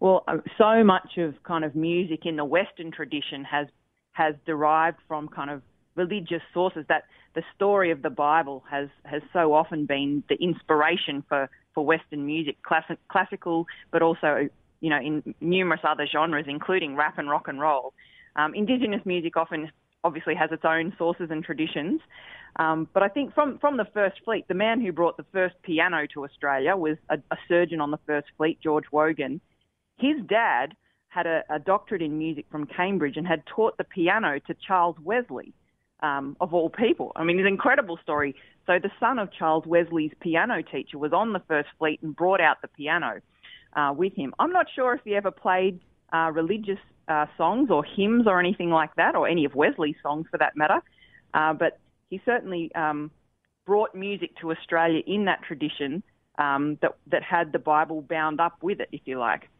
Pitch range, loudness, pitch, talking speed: 150-185 Hz, -25 LUFS, 165 Hz, 190 wpm